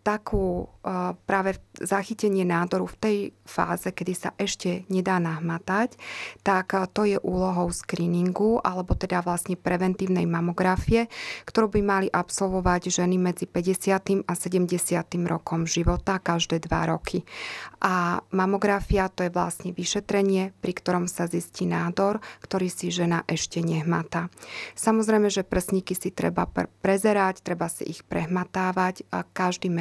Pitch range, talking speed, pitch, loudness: 175-195 Hz, 135 wpm, 185 Hz, -26 LUFS